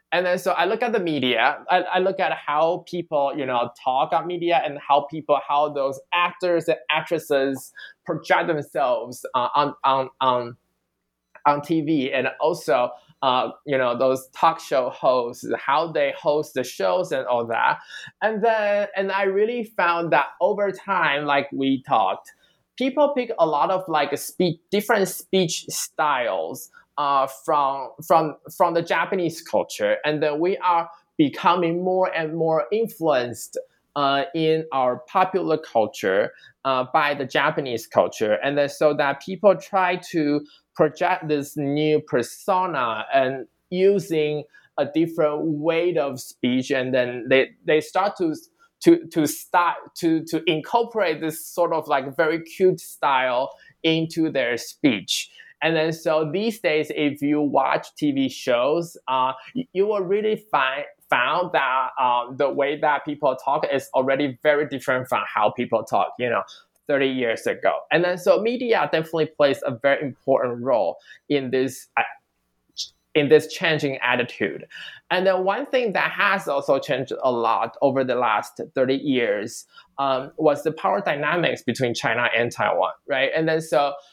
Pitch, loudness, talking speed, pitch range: 155 Hz, -22 LUFS, 160 wpm, 135-180 Hz